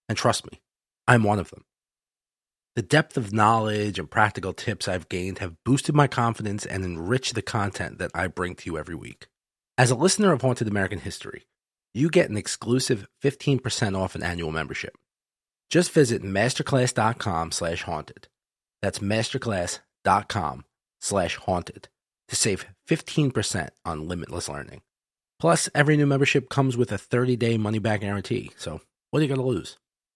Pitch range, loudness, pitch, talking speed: 95-130 Hz, -25 LUFS, 110 Hz, 150 wpm